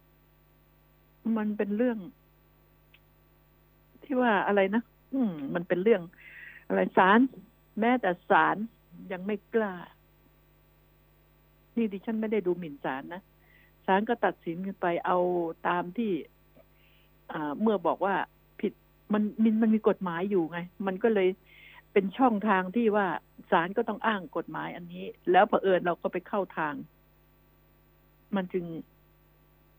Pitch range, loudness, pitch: 180-225 Hz, -28 LUFS, 195 Hz